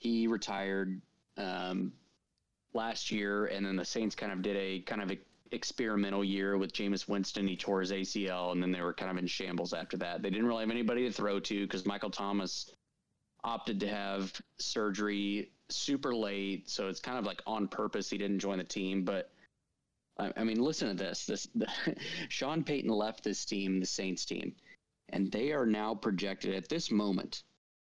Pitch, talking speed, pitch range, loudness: 100 Hz, 190 wpm, 95-105 Hz, -36 LUFS